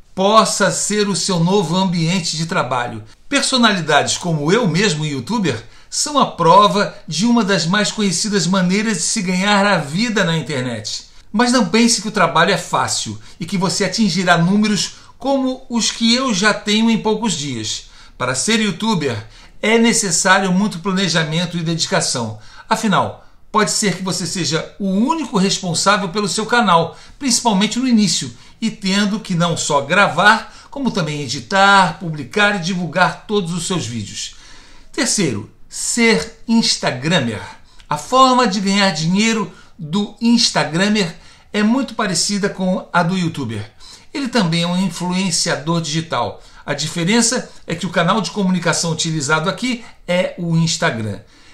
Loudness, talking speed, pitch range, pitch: -16 LUFS, 150 wpm, 165-215 Hz, 190 Hz